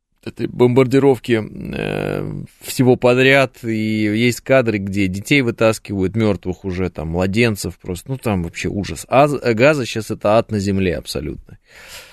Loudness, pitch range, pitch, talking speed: -17 LUFS, 100-125 Hz, 110 Hz, 140 wpm